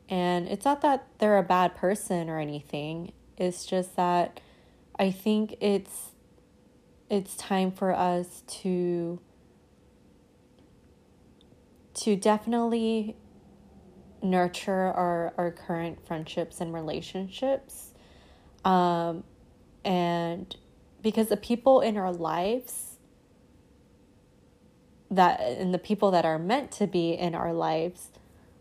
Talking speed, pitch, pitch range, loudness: 105 wpm, 180 Hz, 170-210 Hz, -28 LUFS